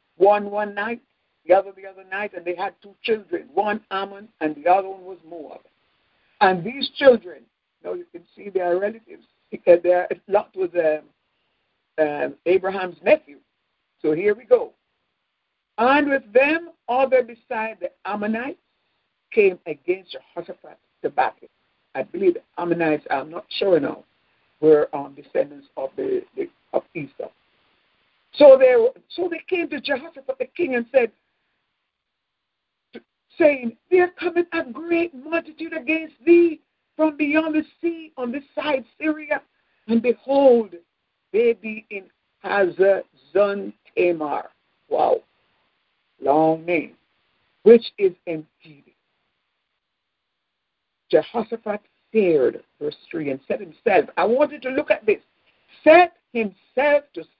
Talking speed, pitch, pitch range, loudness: 135 wpm, 255 Hz, 195-330 Hz, -21 LUFS